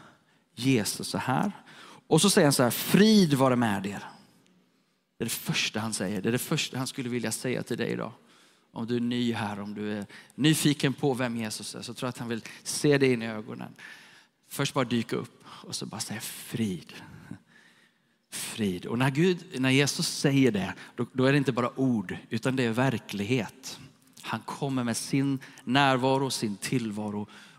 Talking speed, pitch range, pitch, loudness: 190 wpm, 115-140 Hz, 130 Hz, -28 LUFS